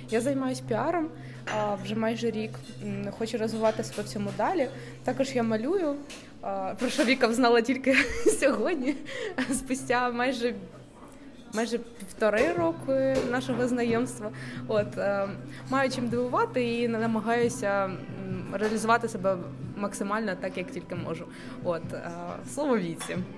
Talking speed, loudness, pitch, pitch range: 110 wpm, -28 LUFS, 235 Hz, 210-260 Hz